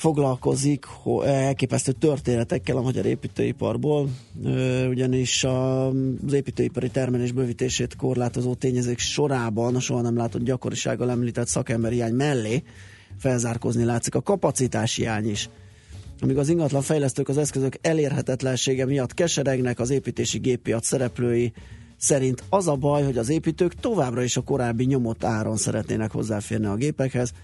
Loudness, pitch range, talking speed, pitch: -24 LUFS, 120-135 Hz, 135 wpm, 125 Hz